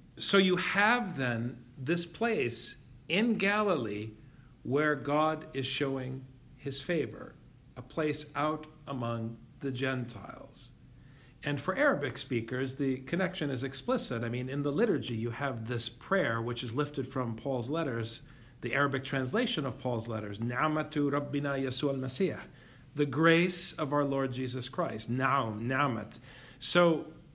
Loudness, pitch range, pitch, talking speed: -31 LUFS, 125-150 Hz, 135 Hz, 130 wpm